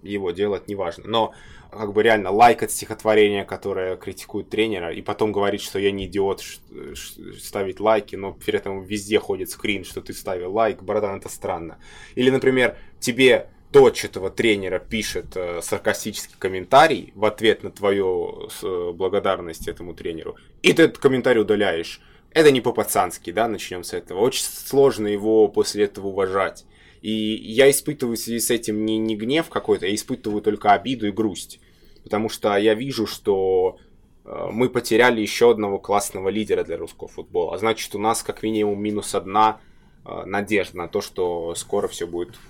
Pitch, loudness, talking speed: 110 Hz, -21 LUFS, 175 wpm